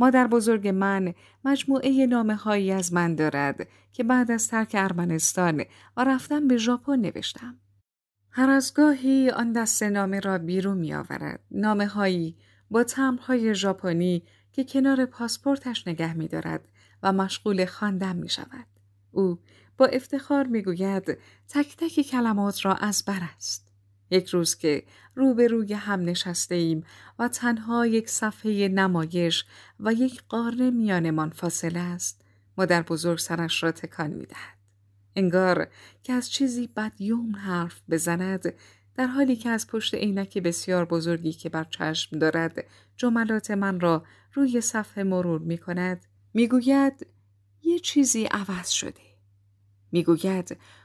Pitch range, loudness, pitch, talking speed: 165-235 Hz, -25 LUFS, 190 Hz, 140 wpm